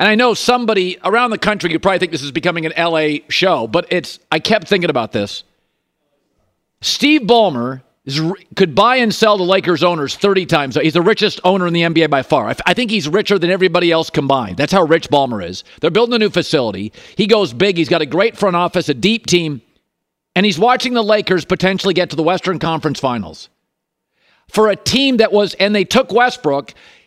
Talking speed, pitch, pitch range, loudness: 210 wpm, 180 Hz, 160-210 Hz, -14 LUFS